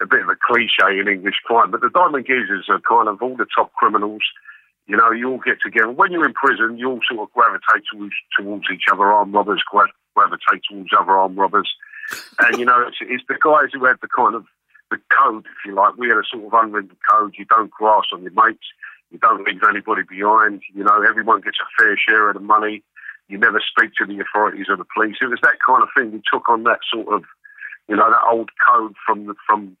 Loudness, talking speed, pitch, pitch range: -16 LUFS, 240 wpm, 115 Hz, 105-130 Hz